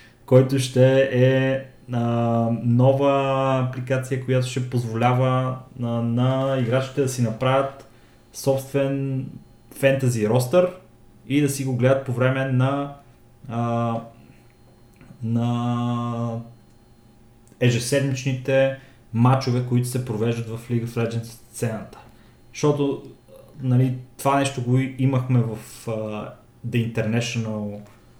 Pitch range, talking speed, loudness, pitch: 115-135 Hz, 100 wpm, -22 LUFS, 125 Hz